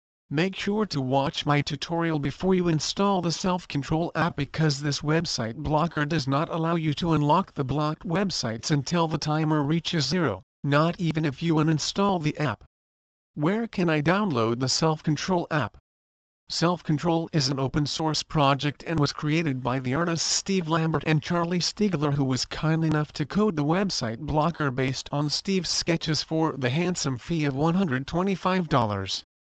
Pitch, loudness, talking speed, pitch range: 155 Hz, -26 LUFS, 170 wpm, 140-170 Hz